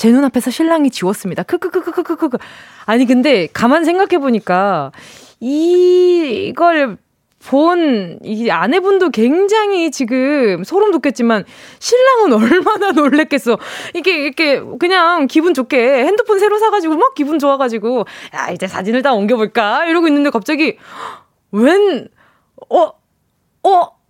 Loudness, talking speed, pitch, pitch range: -13 LUFS, 285 characters per minute, 290 Hz, 245-355 Hz